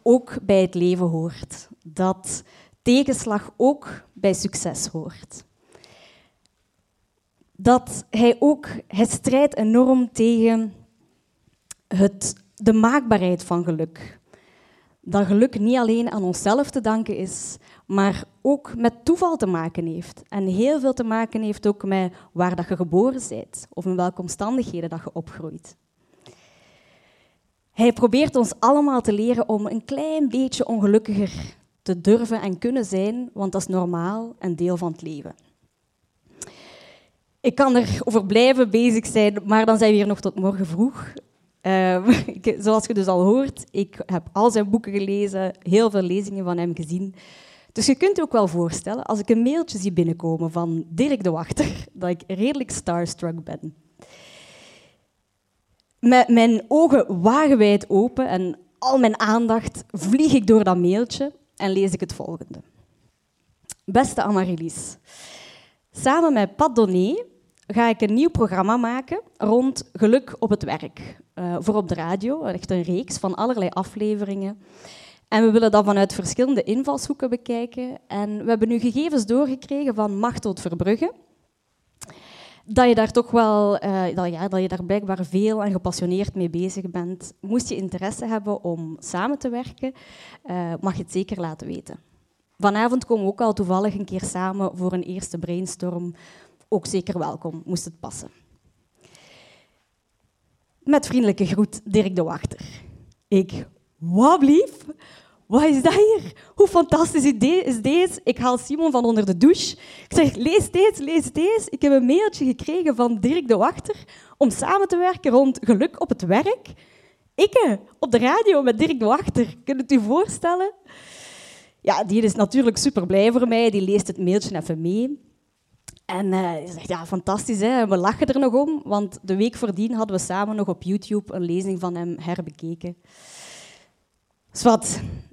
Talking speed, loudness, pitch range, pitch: 160 wpm, -21 LUFS, 185-250 Hz, 210 Hz